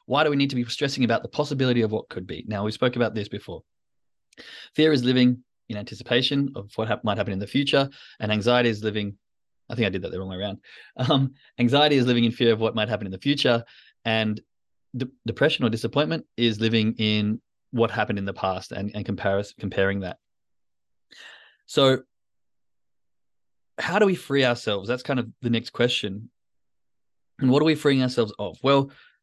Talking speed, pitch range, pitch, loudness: 200 wpm, 105-135 Hz, 120 Hz, -24 LUFS